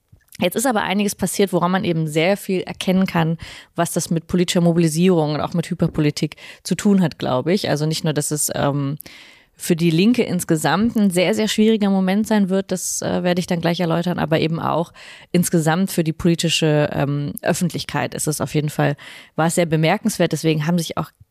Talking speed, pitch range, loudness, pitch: 205 wpm, 160-185 Hz, -19 LUFS, 170 Hz